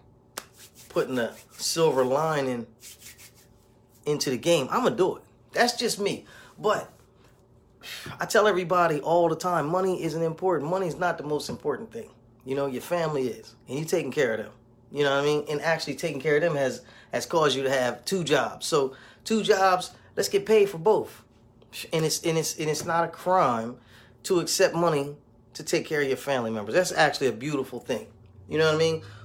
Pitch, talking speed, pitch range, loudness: 155 Hz, 200 wpm, 135-180 Hz, -26 LUFS